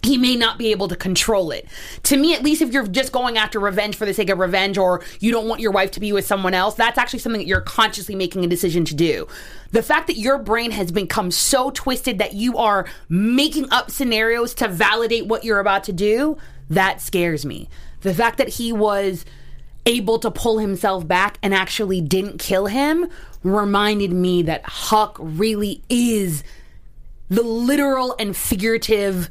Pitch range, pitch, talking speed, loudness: 190-235 Hz, 210 Hz, 195 wpm, -19 LUFS